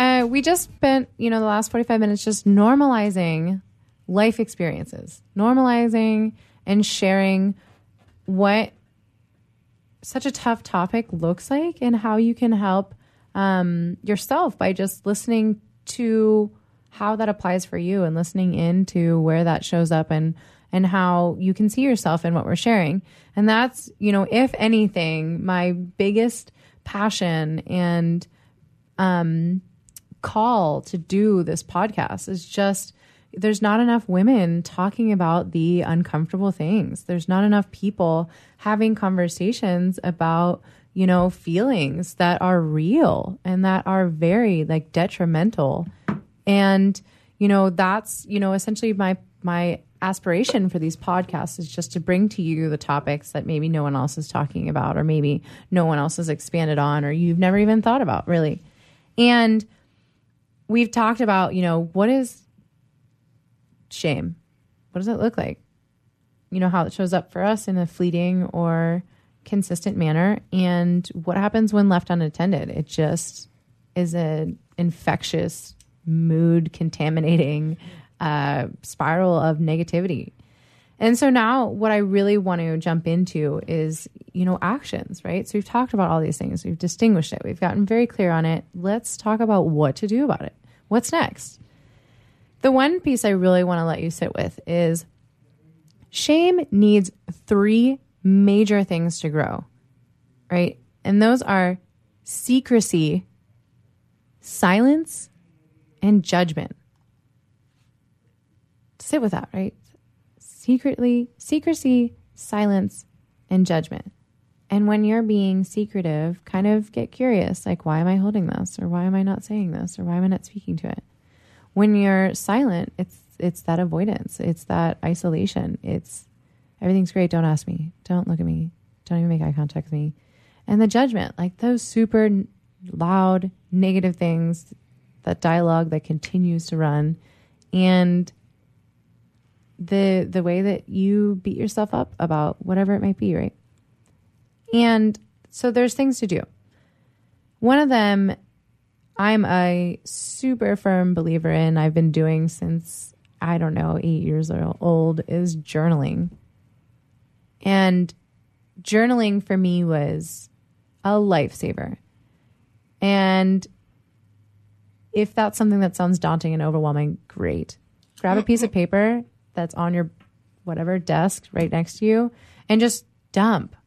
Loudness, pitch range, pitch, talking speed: -21 LUFS, 155-205 Hz, 180 Hz, 145 wpm